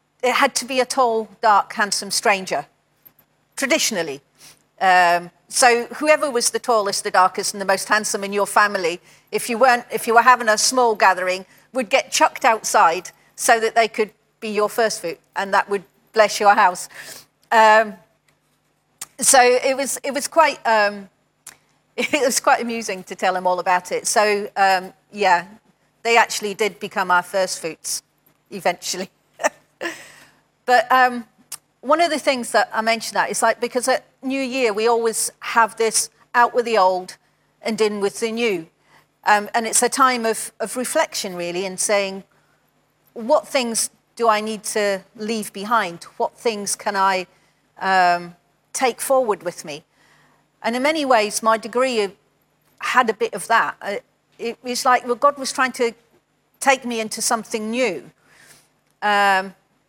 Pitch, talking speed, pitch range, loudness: 220 Hz, 165 wpm, 195-245 Hz, -19 LUFS